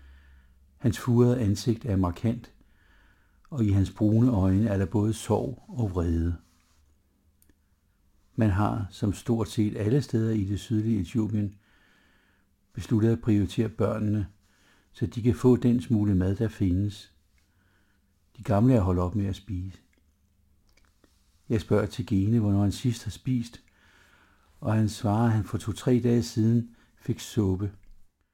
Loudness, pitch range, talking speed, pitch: -27 LUFS, 95-115 Hz, 145 wpm, 105 Hz